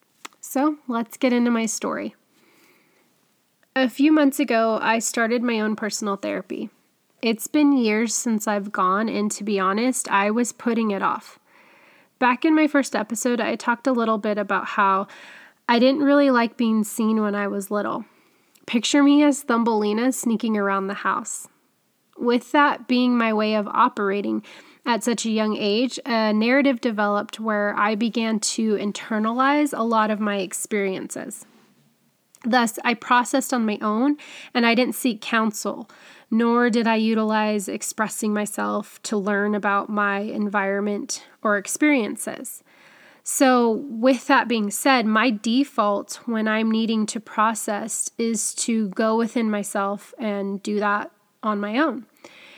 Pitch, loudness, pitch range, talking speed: 225 Hz, -22 LUFS, 210-255 Hz, 150 wpm